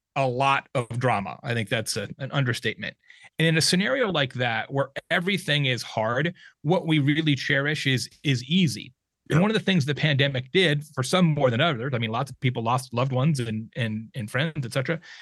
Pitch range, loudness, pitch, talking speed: 125-160 Hz, -24 LUFS, 140 Hz, 215 wpm